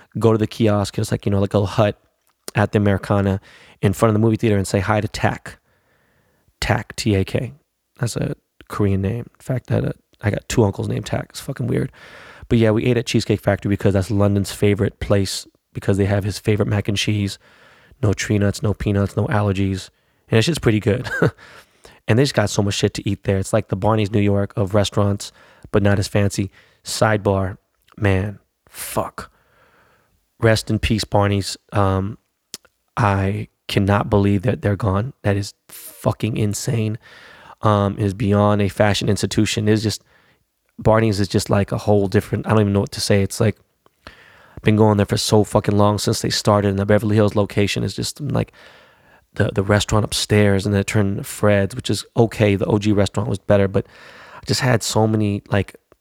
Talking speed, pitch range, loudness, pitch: 200 wpm, 100-110 Hz, -19 LUFS, 105 Hz